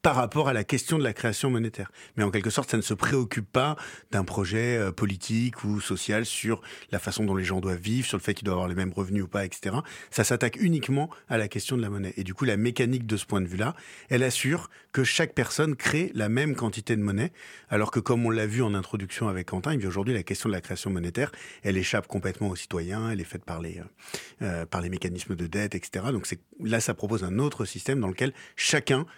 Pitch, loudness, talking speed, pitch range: 110 Hz, -28 LUFS, 245 wpm, 95-125 Hz